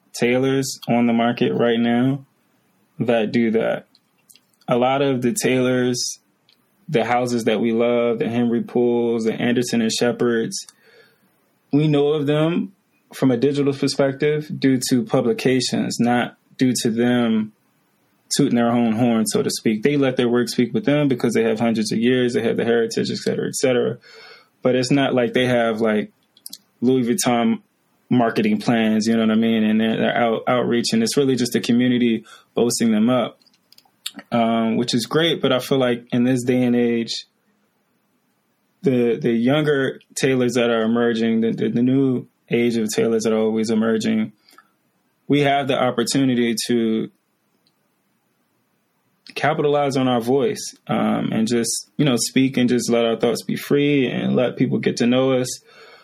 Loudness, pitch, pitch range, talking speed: -19 LUFS, 120 Hz, 115-135 Hz, 170 wpm